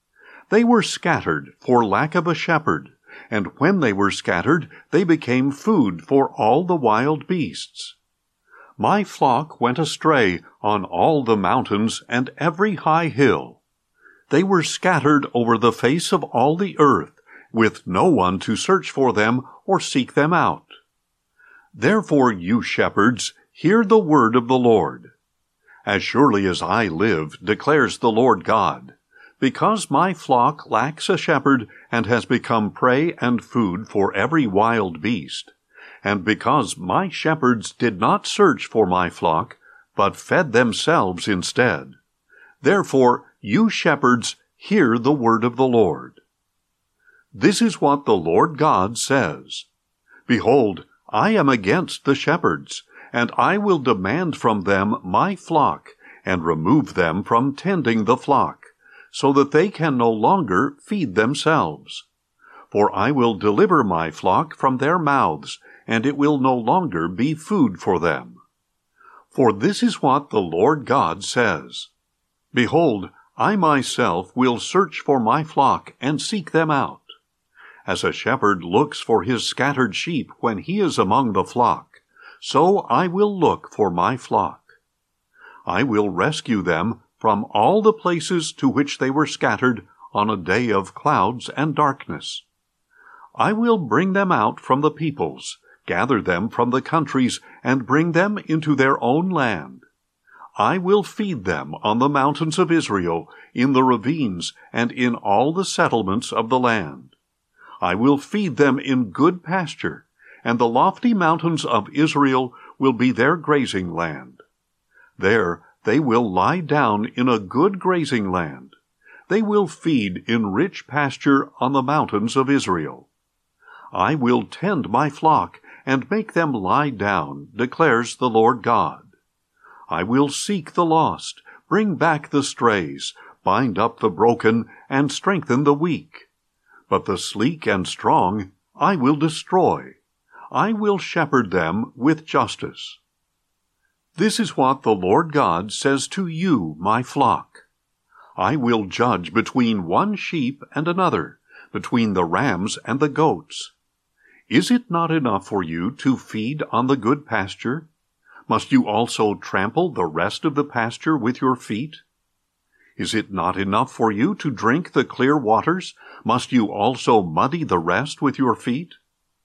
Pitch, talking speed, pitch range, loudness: 140 Hz, 150 wpm, 115-175 Hz, -20 LUFS